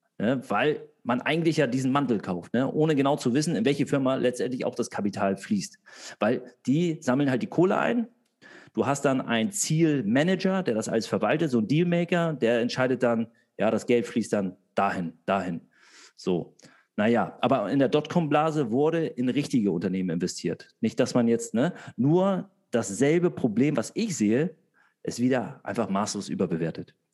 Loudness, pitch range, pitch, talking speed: -26 LUFS, 115-170 Hz, 140 Hz, 170 wpm